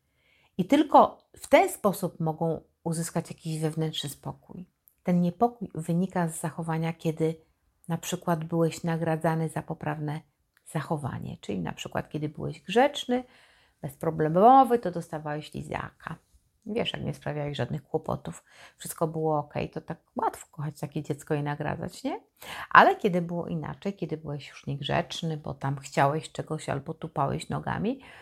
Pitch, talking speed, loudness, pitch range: 160 Hz, 140 wpm, -28 LUFS, 155-175 Hz